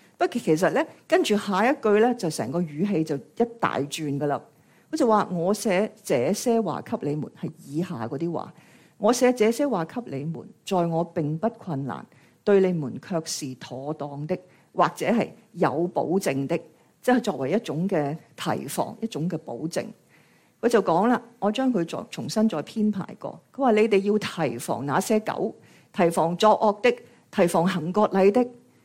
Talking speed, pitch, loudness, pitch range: 250 characters per minute, 185 Hz, -25 LUFS, 160-220 Hz